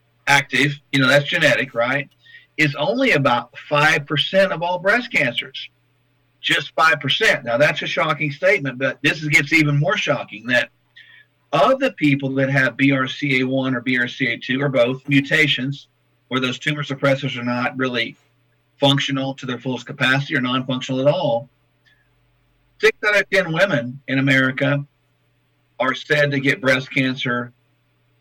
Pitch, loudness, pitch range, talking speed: 140 Hz, -18 LUFS, 130-145 Hz, 145 wpm